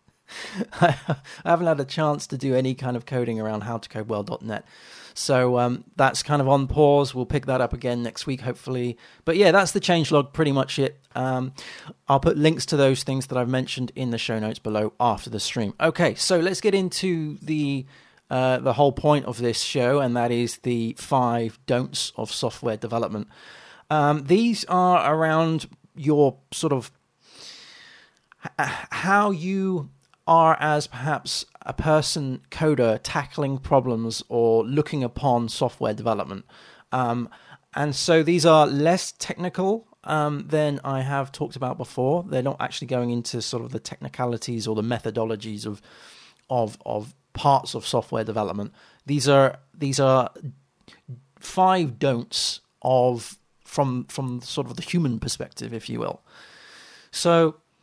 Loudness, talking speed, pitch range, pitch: -23 LUFS, 155 wpm, 120-155 Hz, 135 Hz